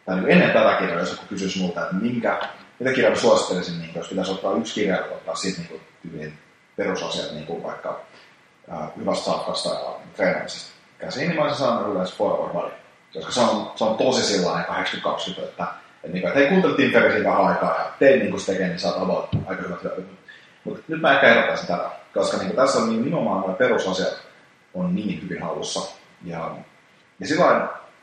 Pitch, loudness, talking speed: 95 Hz, -22 LUFS, 165 wpm